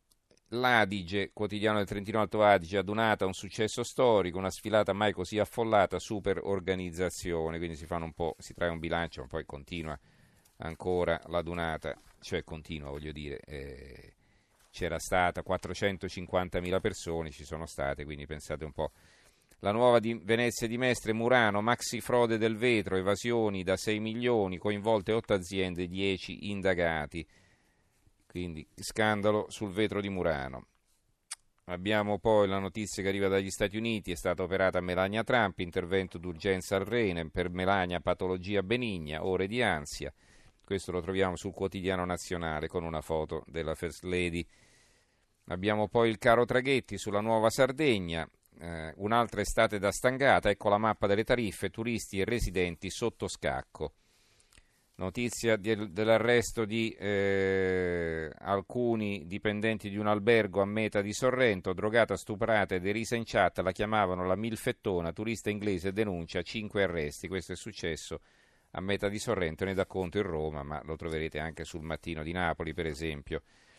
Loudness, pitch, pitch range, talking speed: -31 LUFS, 95 Hz, 90-110 Hz, 150 wpm